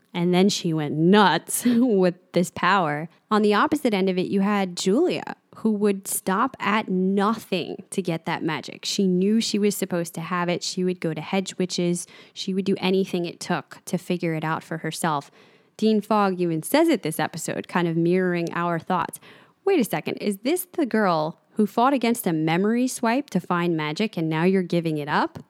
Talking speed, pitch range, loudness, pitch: 200 wpm, 170-210 Hz, -23 LUFS, 190 Hz